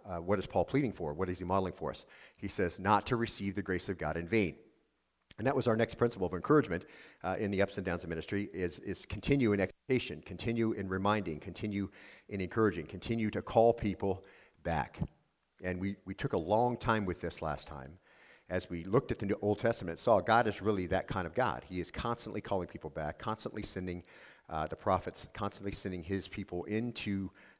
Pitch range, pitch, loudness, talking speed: 90-110 Hz, 100 Hz, -35 LUFS, 215 wpm